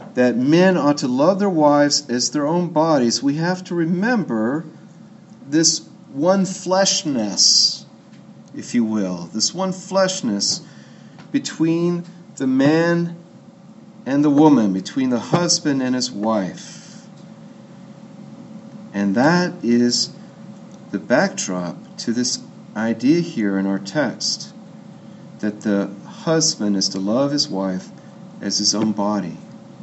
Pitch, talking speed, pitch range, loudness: 165 Hz, 120 wpm, 120-195 Hz, -19 LUFS